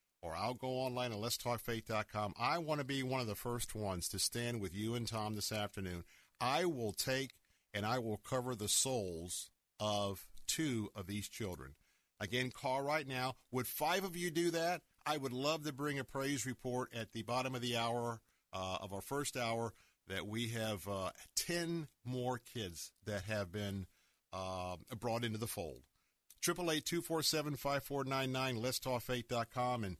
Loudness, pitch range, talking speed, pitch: -40 LUFS, 100-130 Hz, 170 wpm, 120 Hz